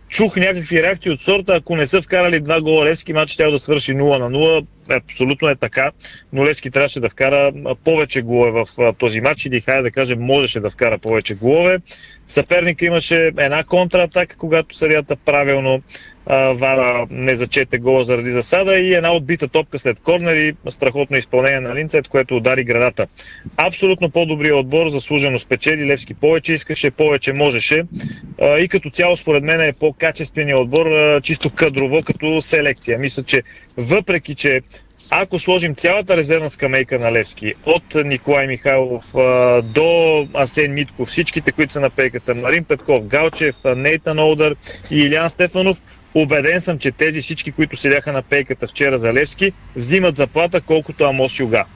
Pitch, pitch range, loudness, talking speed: 145 Hz, 130-160 Hz, -16 LUFS, 160 wpm